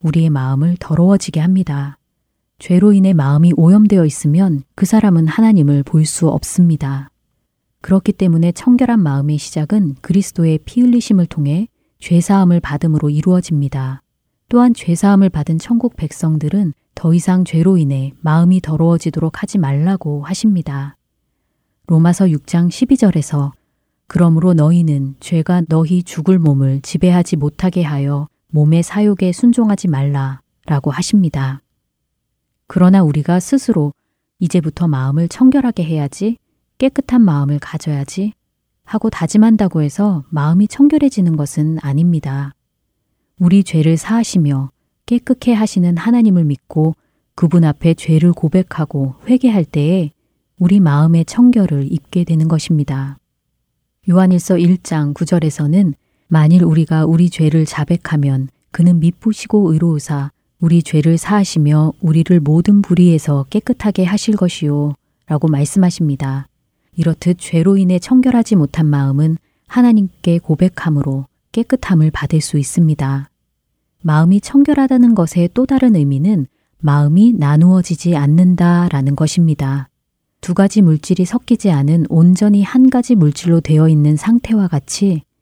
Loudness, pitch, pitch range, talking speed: -13 LUFS, 170 Hz, 150-190 Hz, 310 characters per minute